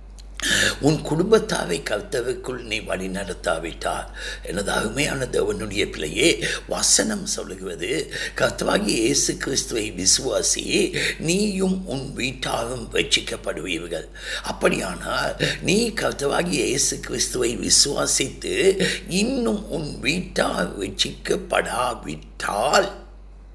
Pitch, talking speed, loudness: 200 Hz, 70 wpm, -22 LUFS